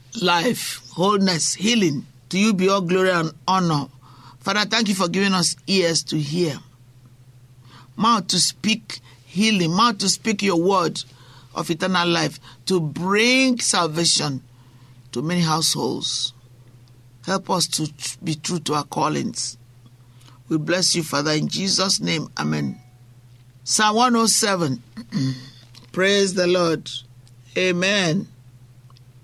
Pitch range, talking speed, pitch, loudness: 125-185 Hz, 120 wpm, 160 Hz, -20 LUFS